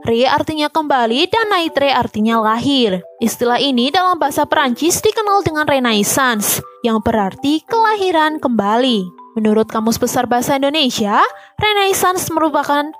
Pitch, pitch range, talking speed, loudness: 275 Hz, 230-315 Hz, 120 wpm, -15 LUFS